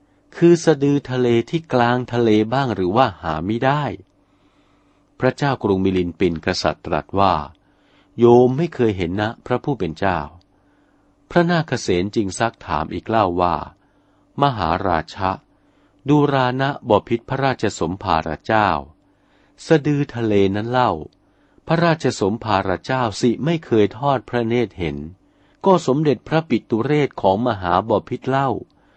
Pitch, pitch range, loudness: 115 Hz, 95-135 Hz, -19 LUFS